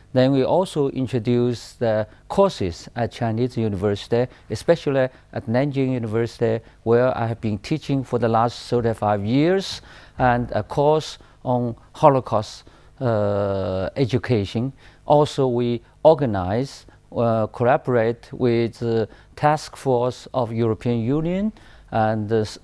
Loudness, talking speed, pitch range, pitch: -22 LUFS, 120 wpm, 110-130 Hz, 120 Hz